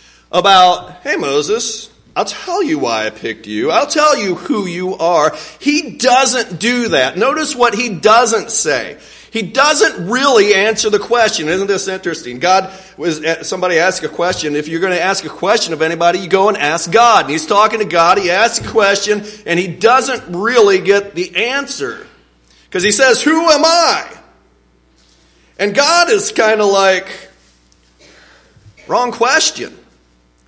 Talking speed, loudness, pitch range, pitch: 165 wpm, -13 LUFS, 165-240 Hz, 195 Hz